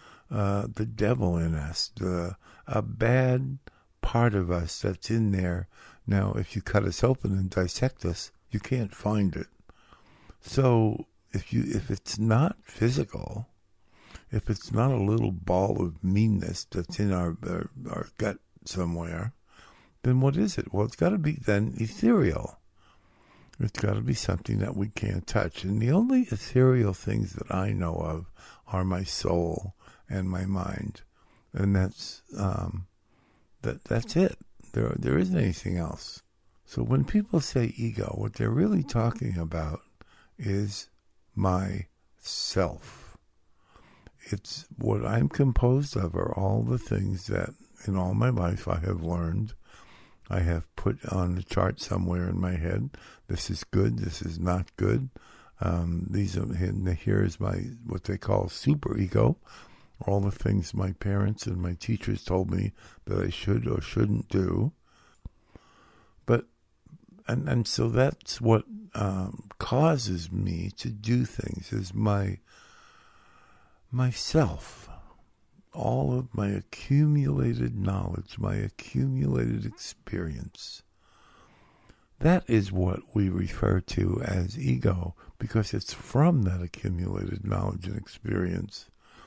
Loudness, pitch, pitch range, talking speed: -28 LUFS, 100 Hz, 90-115 Hz, 140 wpm